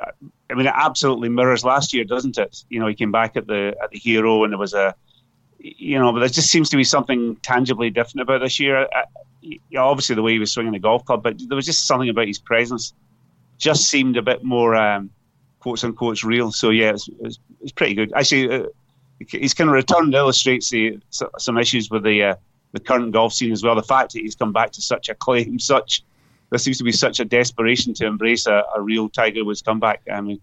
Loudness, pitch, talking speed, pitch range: -18 LUFS, 120 Hz, 235 wpm, 110-130 Hz